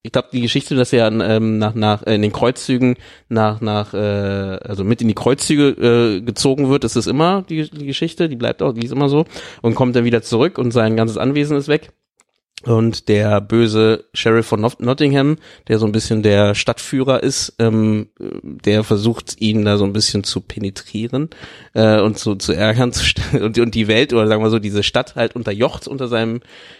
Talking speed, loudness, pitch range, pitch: 205 wpm, -16 LUFS, 105-130 Hz, 115 Hz